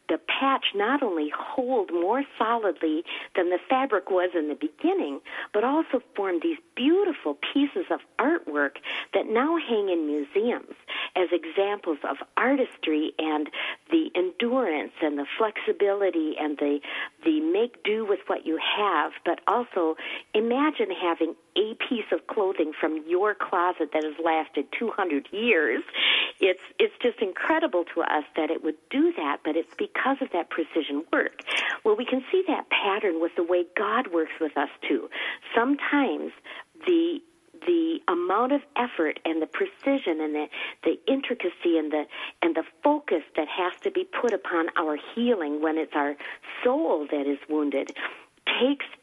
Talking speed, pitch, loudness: 160 wpm, 205 Hz, -26 LUFS